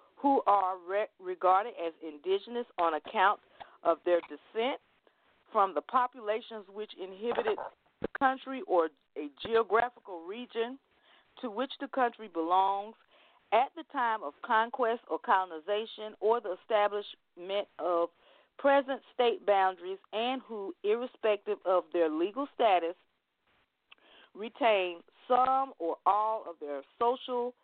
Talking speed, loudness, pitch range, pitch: 120 wpm, -31 LUFS, 185-250 Hz, 215 Hz